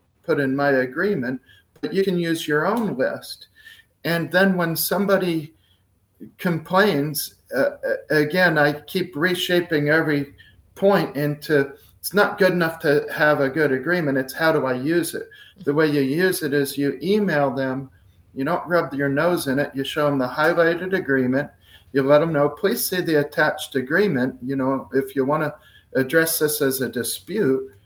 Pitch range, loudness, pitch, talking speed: 135-180 Hz, -21 LUFS, 150 Hz, 175 wpm